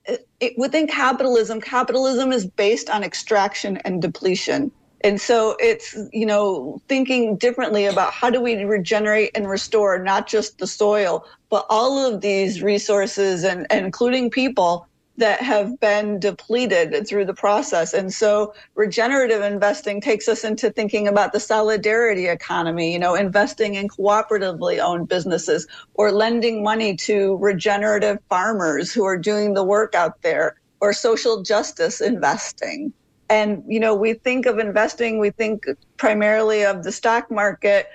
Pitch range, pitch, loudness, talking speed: 200-230 Hz, 215 Hz, -20 LUFS, 150 wpm